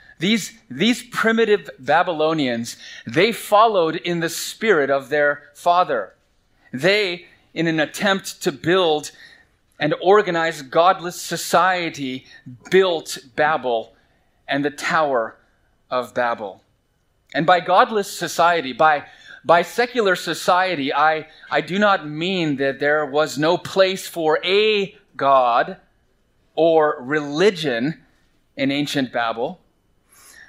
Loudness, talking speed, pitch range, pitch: -19 LUFS, 110 wpm, 145-185 Hz, 165 Hz